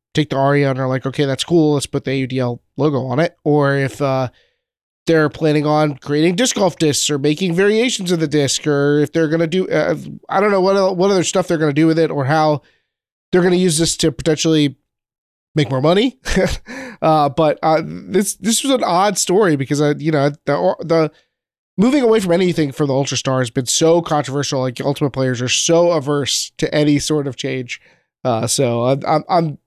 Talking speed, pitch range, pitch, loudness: 220 wpm, 140-170 Hz, 150 Hz, -16 LUFS